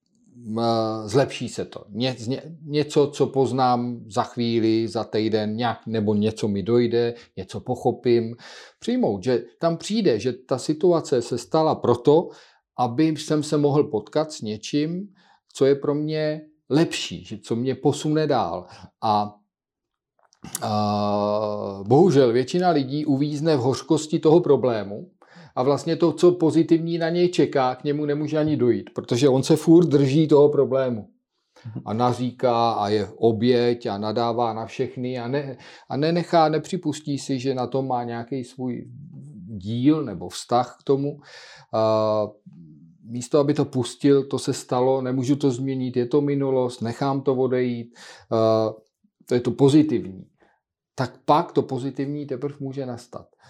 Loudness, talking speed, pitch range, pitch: -22 LUFS, 145 wpm, 120-150 Hz, 130 Hz